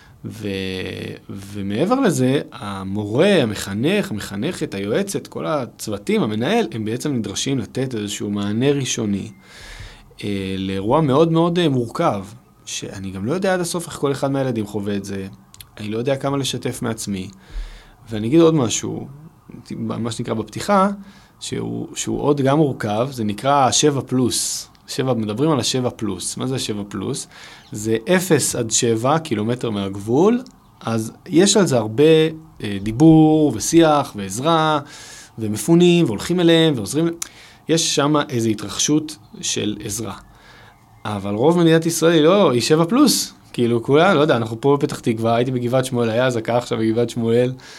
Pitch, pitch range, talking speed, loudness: 120 Hz, 110-150 Hz, 145 wpm, -19 LUFS